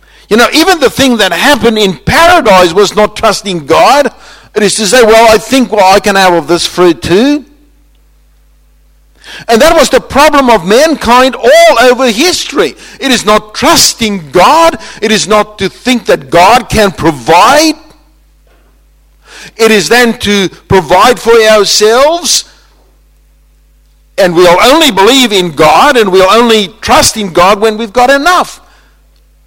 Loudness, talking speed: -6 LUFS, 155 wpm